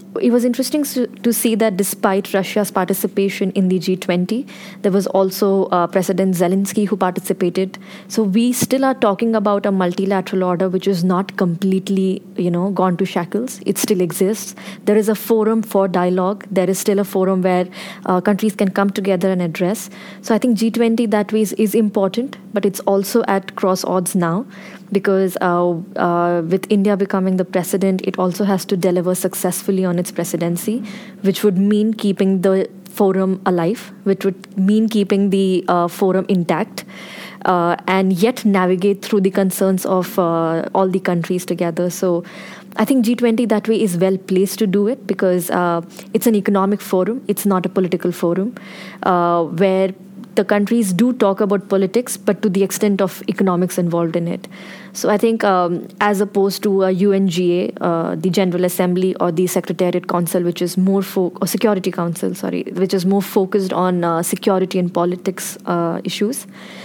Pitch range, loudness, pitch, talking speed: 185-205 Hz, -17 LUFS, 195 Hz, 175 wpm